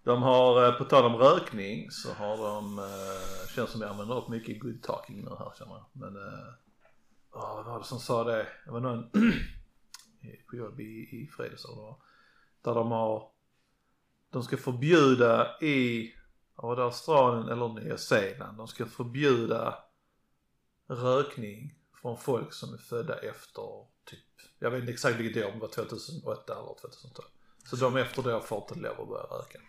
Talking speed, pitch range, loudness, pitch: 175 wpm, 115-145 Hz, -29 LUFS, 120 Hz